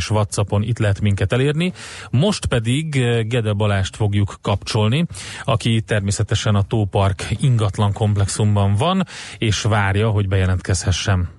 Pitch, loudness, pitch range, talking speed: 105 Hz, -19 LUFS, 100-115 Hz, 120 wpm